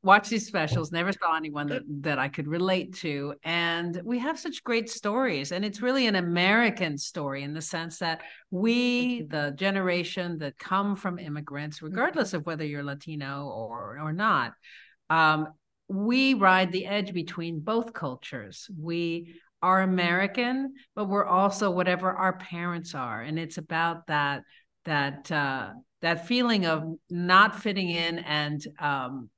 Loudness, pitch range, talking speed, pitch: -27 LUFS, 155-200 Hz, 155 wpm, 175 Hz